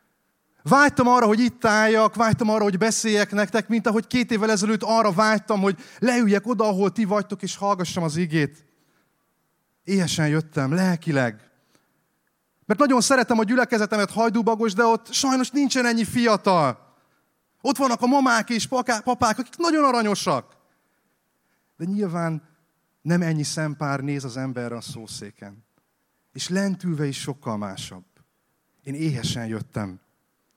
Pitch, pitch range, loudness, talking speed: 205 Hz, 155-230 Hz, -22 LUFS, 135 wpm